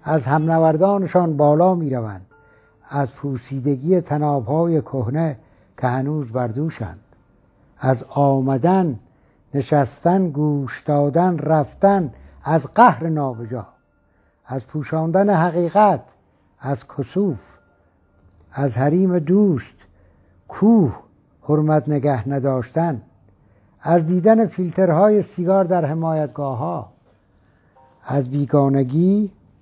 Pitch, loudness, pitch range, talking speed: 145 Hz, -19 LUFS, 125-170 Hz, 85 wpm